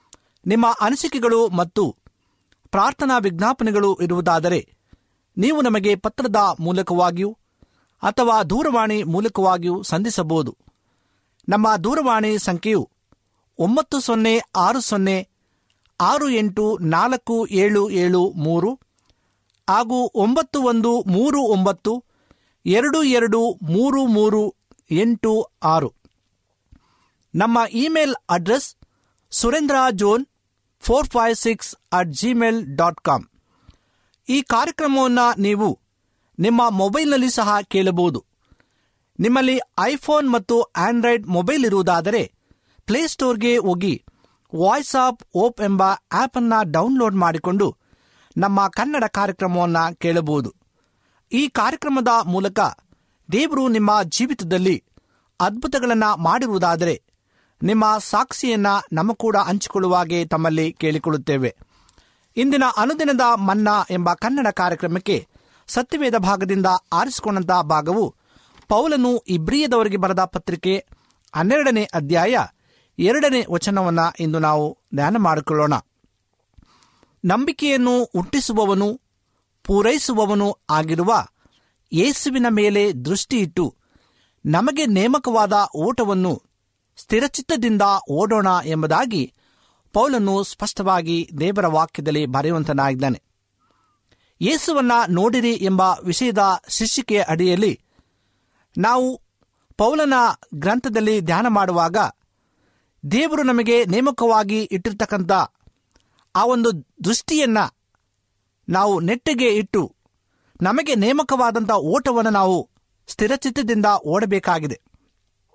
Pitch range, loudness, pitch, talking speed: 170-235 Hz, -19 LUFS, 205 Hz, 85 wpm